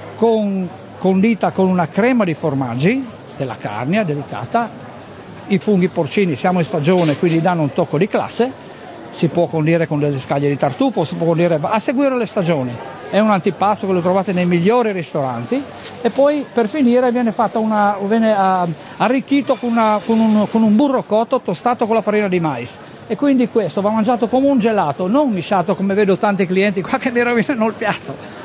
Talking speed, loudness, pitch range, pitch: 185 wpm, -17 LUFS, 175-230 Hz, 200 Hz